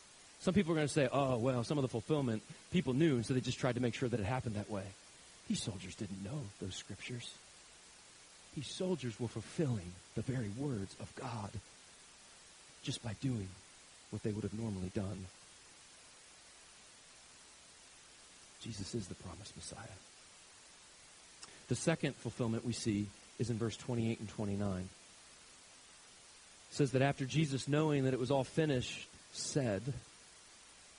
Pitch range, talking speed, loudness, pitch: 100-135 Hz, 155 wpm, -38 LUFS, 120 Hz